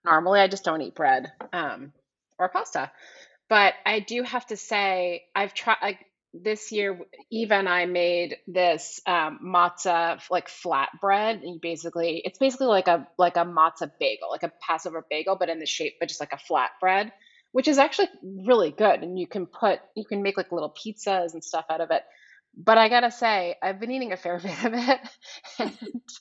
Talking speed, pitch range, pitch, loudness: 200 wpm, 170-220 Hz, 190 Hz, -25 LUFS